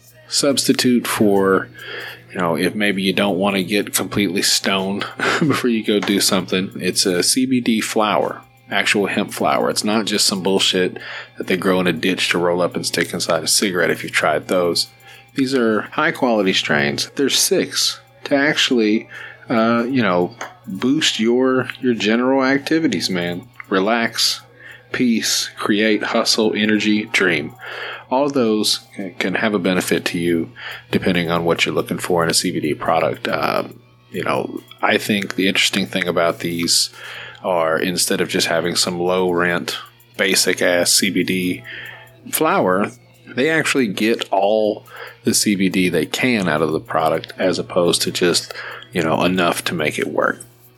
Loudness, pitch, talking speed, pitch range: -18 LUFS, 105 Hz, 160 wpm, 90-120 Hz